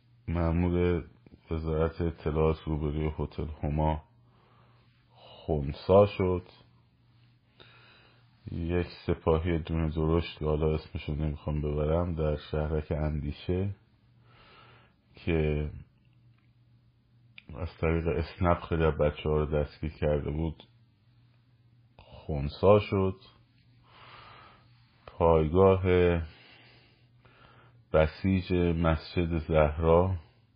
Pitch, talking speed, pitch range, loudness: 90 Hz, 75 wpm, 80-120 Hz, -29 LUFS